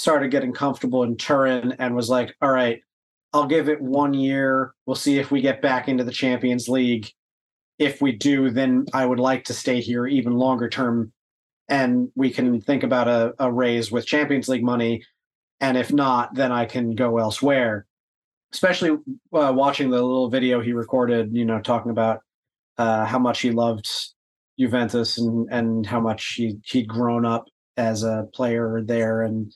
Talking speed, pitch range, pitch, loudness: 180 wpm, 115-130 Hz, 125 Hz, -22 LUFS